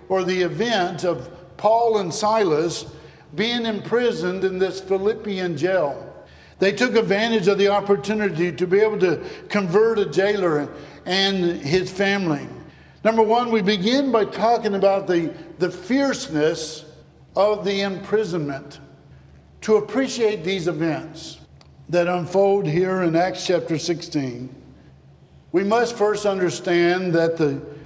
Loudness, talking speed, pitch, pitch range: -21 LUFS, 125 wpm, 185 Hz, 165-210 Hz